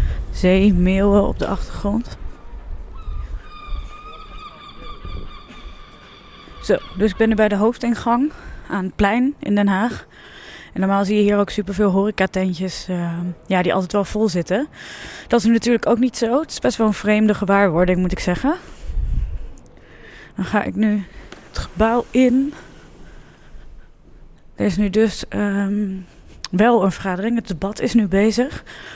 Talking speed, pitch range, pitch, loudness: 145 wpm, 190-230 Hz, 205 Hz, -19 LUFS